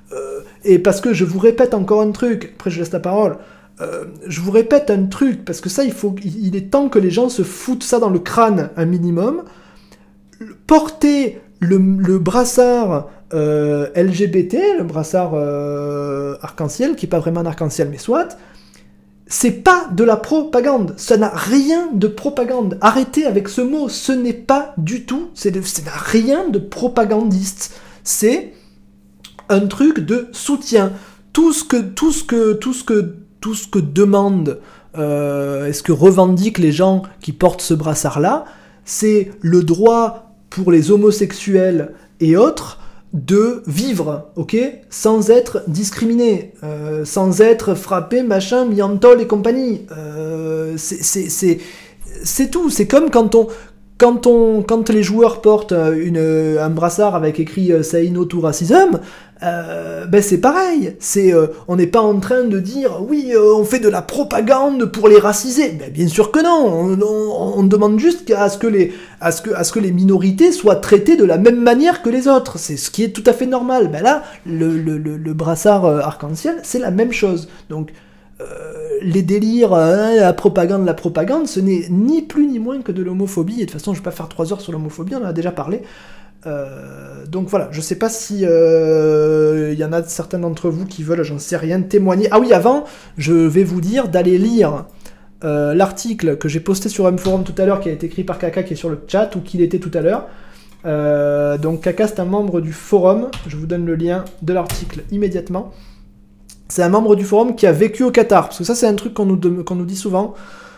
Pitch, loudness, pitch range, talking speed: 195 Hz, -15 LUFS, 170-230 Hz, 195 wpm